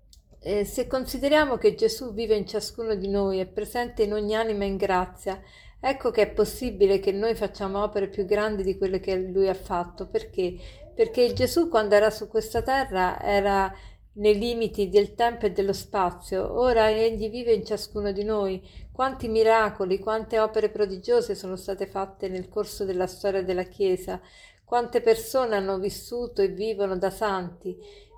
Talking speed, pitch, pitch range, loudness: 165 wpm, 210 Hz, 195-225 Hz, -26 LUFS